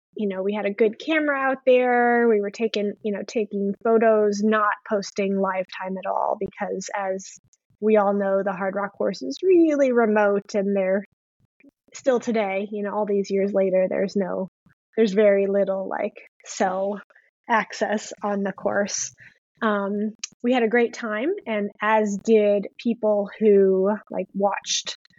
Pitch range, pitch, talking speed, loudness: 200-225 Hz, 205 Hz, 160 wpm, -23 LUFS